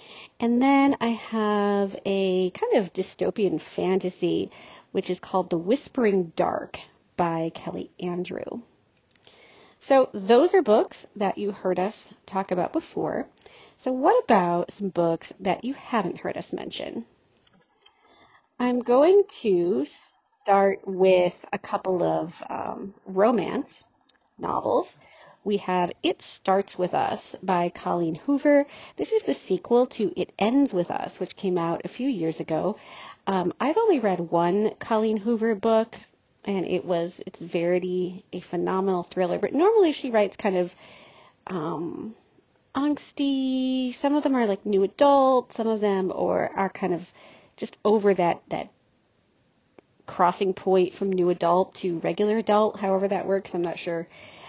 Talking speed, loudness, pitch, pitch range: 145 wpm, -25 LUFS, 195 Hz, 180-245 Hz